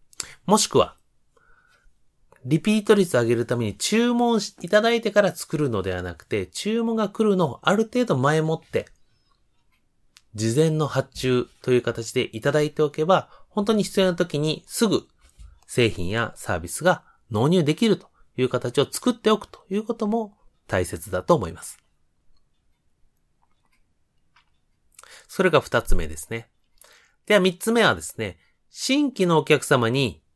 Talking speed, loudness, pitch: 275 characters per minute, -23 LUFS, 155 Hz